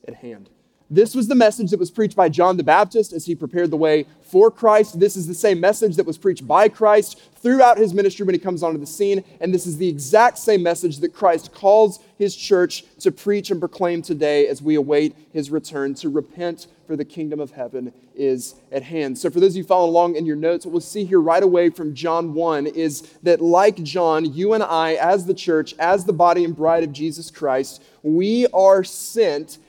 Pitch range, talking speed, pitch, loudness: 155-200 Hz, 225 wpm, 175 Hz, -18 LUFS